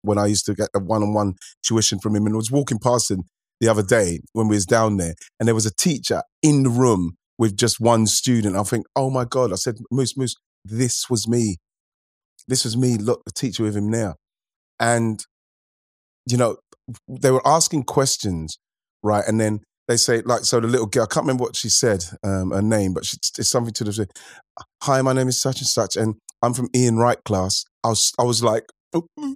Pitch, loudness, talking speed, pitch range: 115 Hz, -20 LUFS, 220 wpm, 105-125 Hz